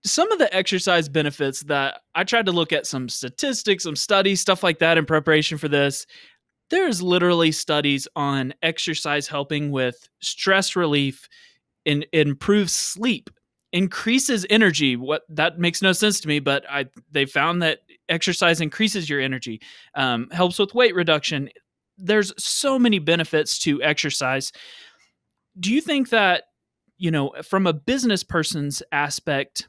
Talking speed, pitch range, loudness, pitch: 150 wpm, 145-195 Hz, -21 LUFS, 165 Hz